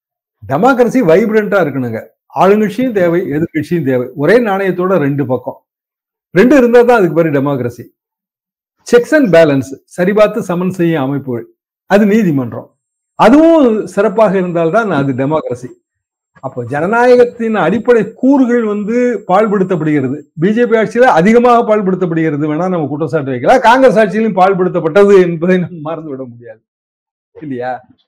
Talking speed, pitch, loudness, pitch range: 115 wpm, 185 Hz, -11 LUFS, 150-225 Hz